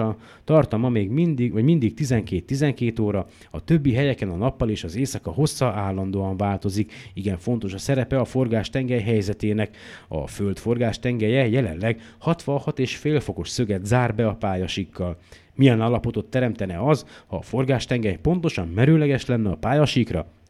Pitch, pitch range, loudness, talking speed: 115 Hz, 100-135 Hz, -23 LUFS, 145 wpm